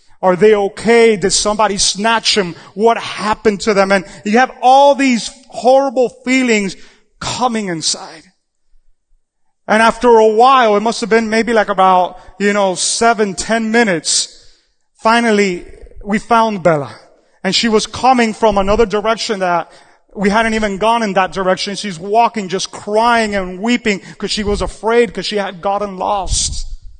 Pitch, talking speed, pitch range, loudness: 210 Hz, 155 wpm, 190-230 Hz, -13 LUFS